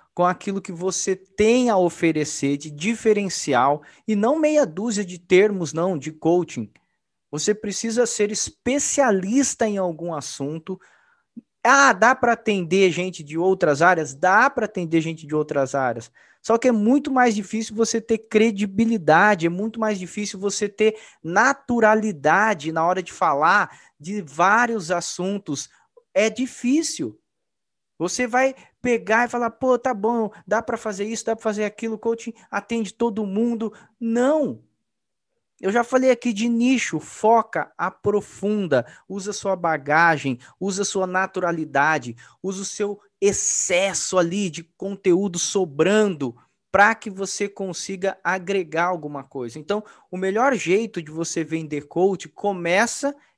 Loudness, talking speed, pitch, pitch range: -21 LUFS, 140 wpm, 200 Hz, 175-225 Hz